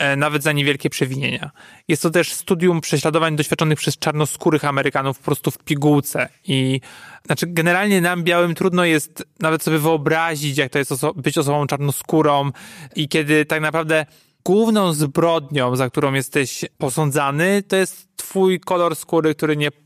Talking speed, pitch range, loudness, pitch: 155 wpm, 145-170 Hz, -19 LUFS, 155 Hz